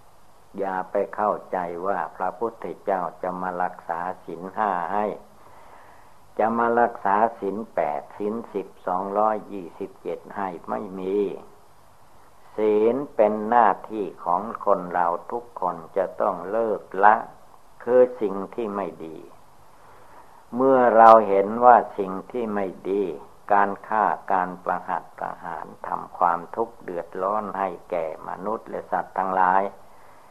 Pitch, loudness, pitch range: 100 Hz, -23 LUFS, 95-115 Hz